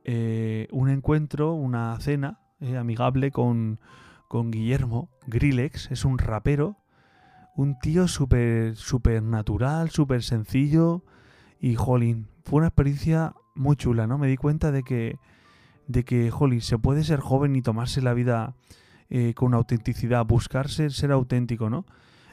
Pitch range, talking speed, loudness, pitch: 115-140 Hz, 135 wpm, -25 LUFS, 125 Hz